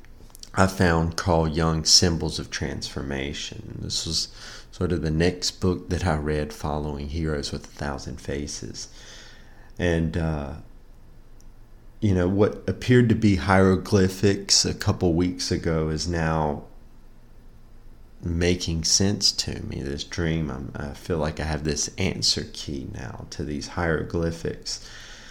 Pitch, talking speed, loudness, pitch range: 90 Hz, 135 wpm, -24 LUFS, 80-100 Hz